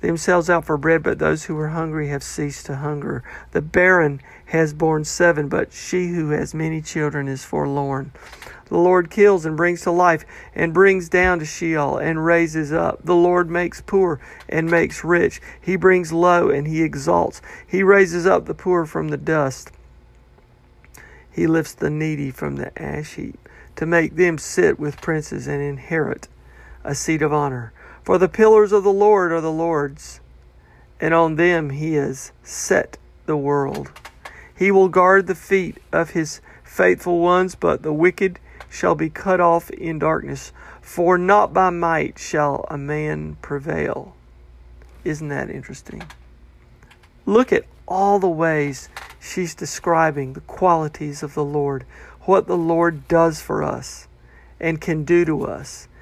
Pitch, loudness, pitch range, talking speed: 160 Hz, -19 LUFS, 140-175 Hz, 160 wpm